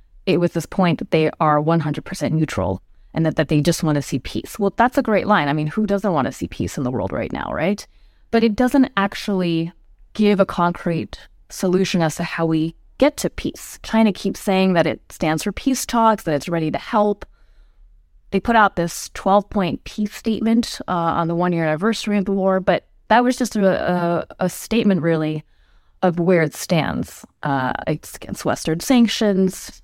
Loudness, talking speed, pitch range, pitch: -20 LUFS, 200 wpm, 160-210 Hz, 180 Hz